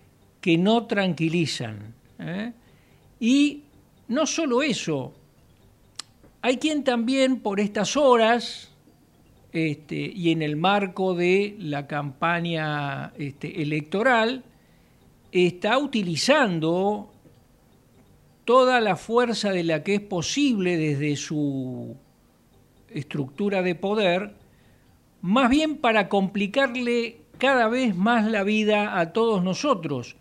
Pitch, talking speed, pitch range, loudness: 200 Hz, 100 wpm, 160-240 Hz, -23 LUFS